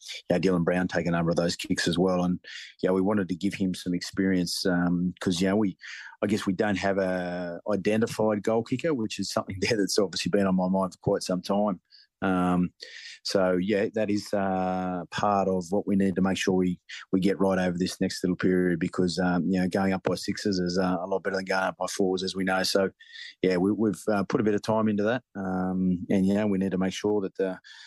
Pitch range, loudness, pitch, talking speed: 90-100 Hz, -27 LUFS, 95 Hz, 245 wpm